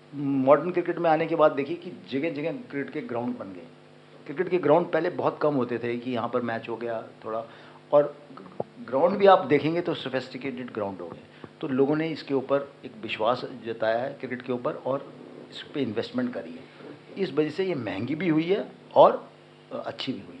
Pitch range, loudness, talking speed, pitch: 125-165 Hz, -26 LUFS, 210 wpm, 145 Hz